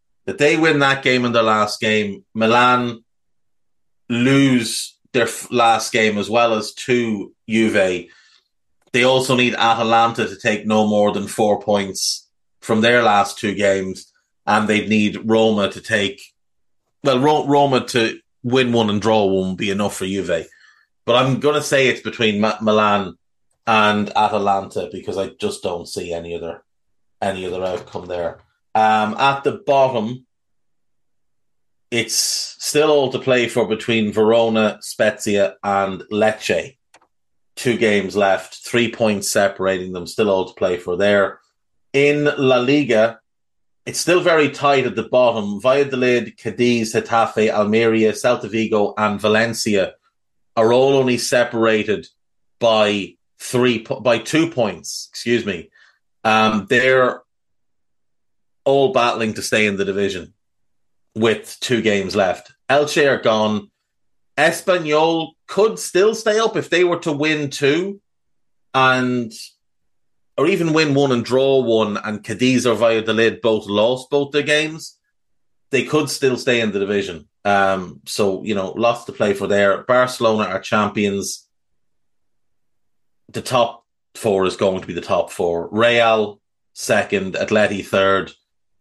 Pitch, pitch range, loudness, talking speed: 110 Hz, 105-125 Hz, -18 LUFS, 145 wpm